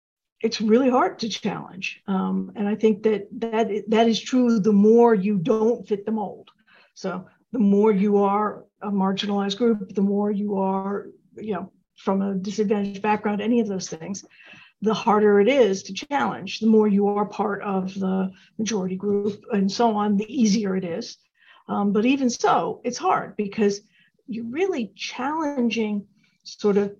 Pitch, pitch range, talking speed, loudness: 210 Hz, 200-225 Hz, 170 wpm, -23 LUFS